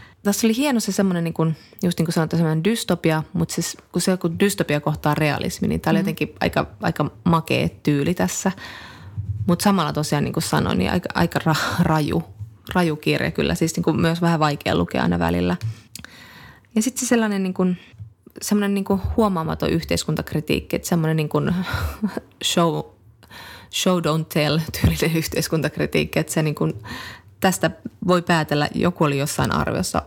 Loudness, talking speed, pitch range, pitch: -21 LUFS, 155 wpm, 115-180 Hz, 160 Hz